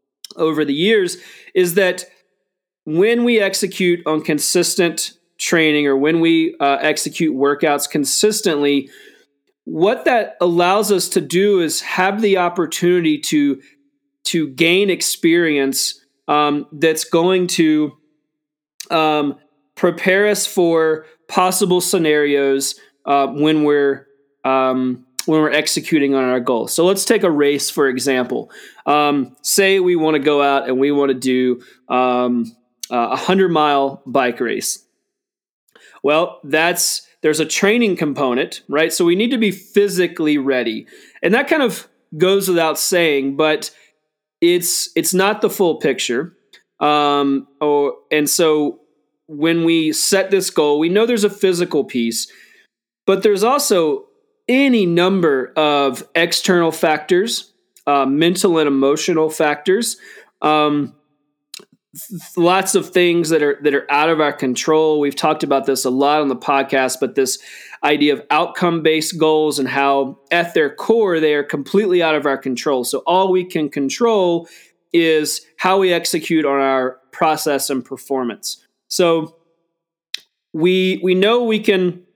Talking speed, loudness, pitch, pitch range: 140 wpm, -16 LUFS, 160 Hz, 145-185 Hz